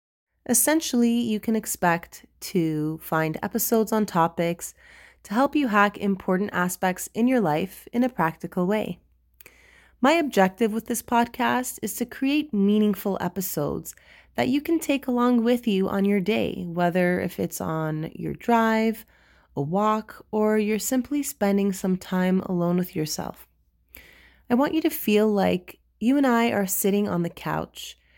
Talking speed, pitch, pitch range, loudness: 155 wpm, 205 Hz, 180-240 Hz, -24 LUFS